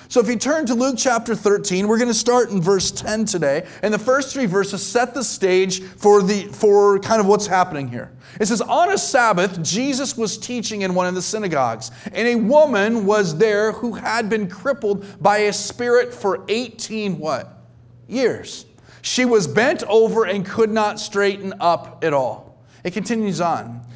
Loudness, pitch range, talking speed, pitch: -19 LUFS, 190-230 Hz, 190 wpm, 210 Hz